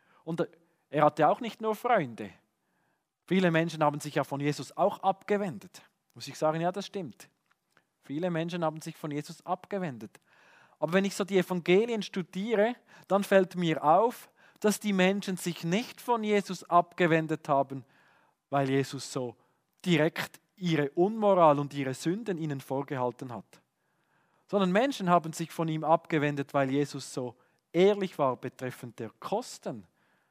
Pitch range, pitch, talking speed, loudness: 145-190 Hz, 165 Hz, 150 wpm, -29 LUFS